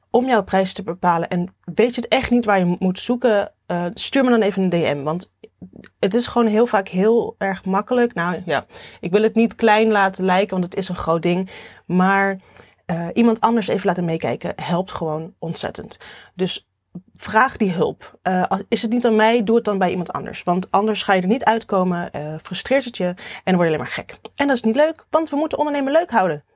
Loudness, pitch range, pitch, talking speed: -19 LUFS, 180-230 Hz, 195 Hz, 225 wpm